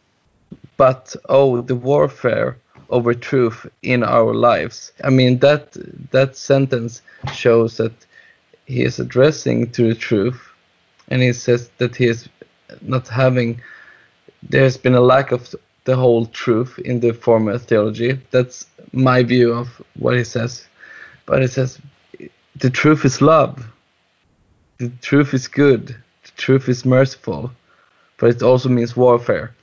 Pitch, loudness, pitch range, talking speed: 125 Hz, -17 LUFS, 120-130 Hz, 140 wpm